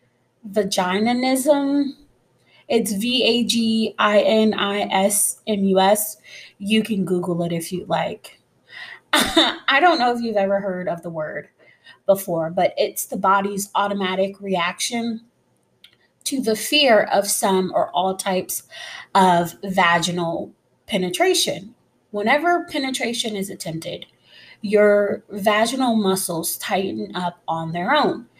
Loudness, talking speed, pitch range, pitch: -20 LUFS, 105 wpm, 185-230 Hz, 200 Hz